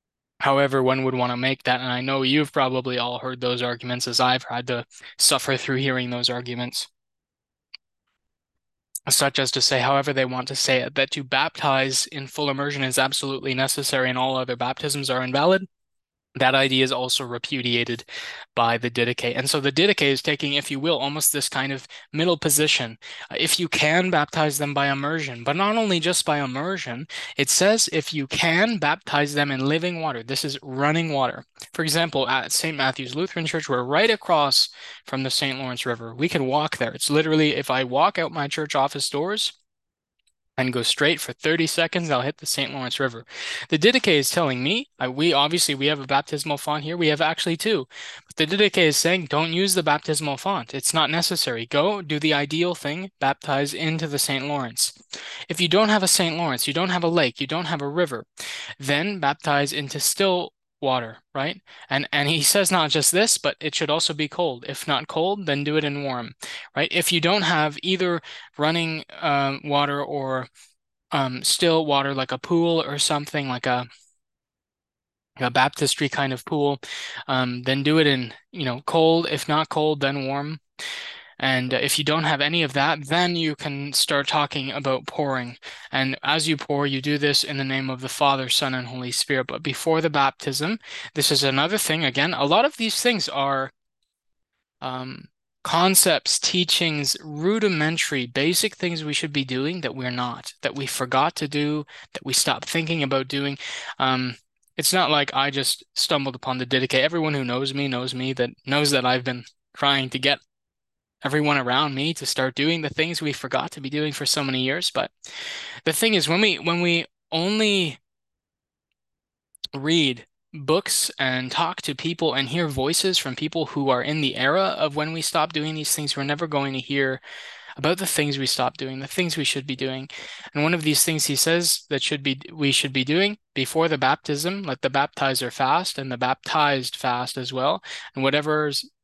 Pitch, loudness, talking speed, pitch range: 145 Hz, -22 LUFS, 195 wpm, 130-160 Hz